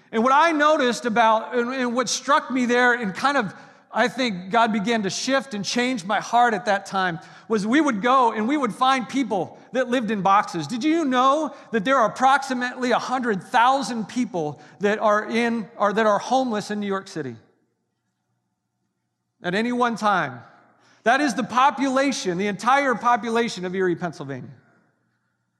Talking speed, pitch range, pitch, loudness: 170 wpm, 195-255 Hz, 230 Hz, -21 LUFS